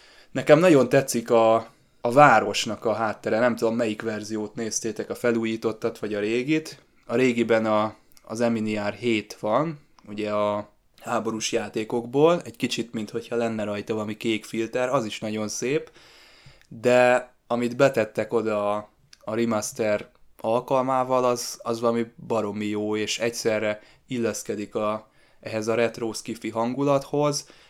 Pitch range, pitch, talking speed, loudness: 110-125 Hz, 115 Hz, 135 wpm, -24 LUFS